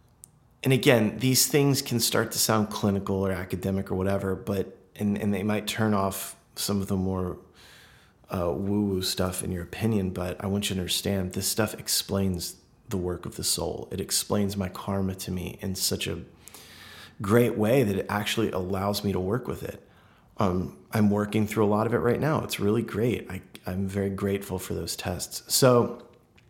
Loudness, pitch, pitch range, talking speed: -27 LUFS, 100 Hz, 95-110 Hz, 195 wpm